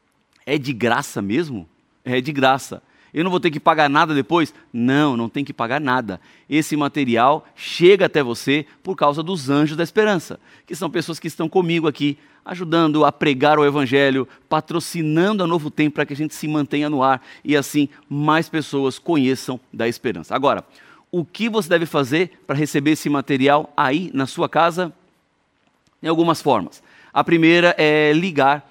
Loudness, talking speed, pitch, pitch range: -19 LUFS, 175 wpm, 150 Hz, 140-165 Hz